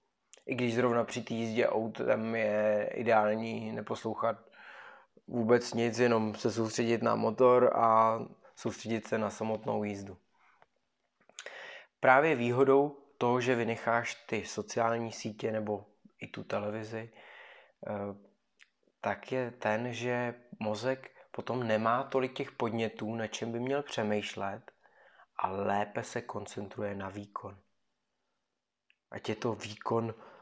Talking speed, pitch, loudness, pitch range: 120 wpm, 115 Hz, -32 LUFS, 110-120 Hz